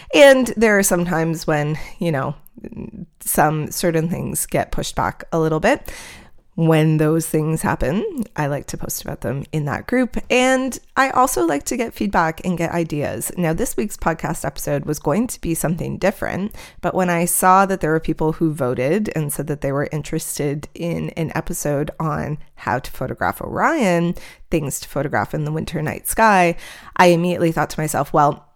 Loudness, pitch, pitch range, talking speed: -19 LUFS, 165 Hz, 150-185 Hz, 185 wpm